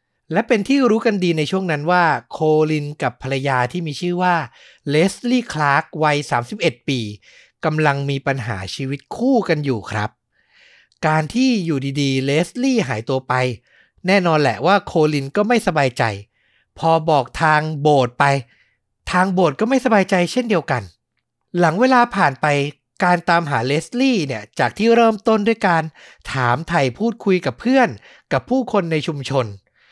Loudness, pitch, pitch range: -18 LUFS, 155 Hz, 135-195 Hz